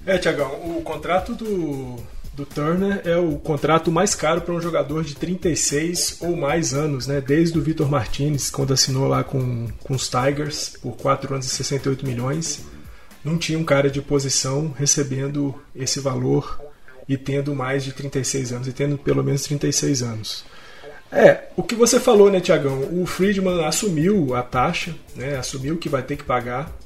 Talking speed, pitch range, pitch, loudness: 170 wpm, 135-165 Hz, 145 Hz, -21 LUFS